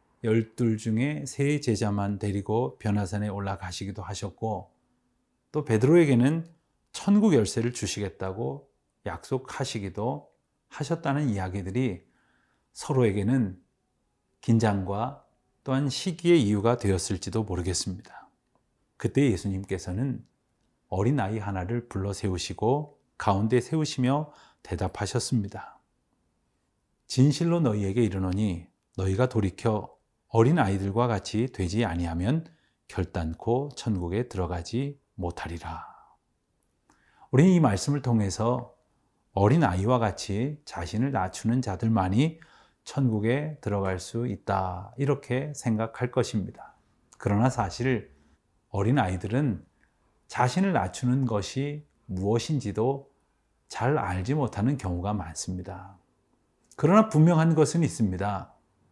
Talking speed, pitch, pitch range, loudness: 265 characters per minute, 110 Hz, 95-130 Hz, -27 LUFS